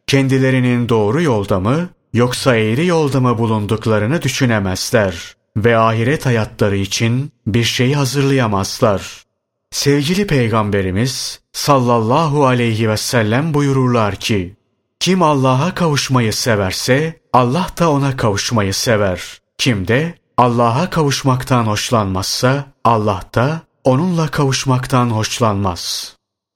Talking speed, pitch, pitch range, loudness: 100 wpm, 125 Hz, 110-140 Hz, -15 LUFS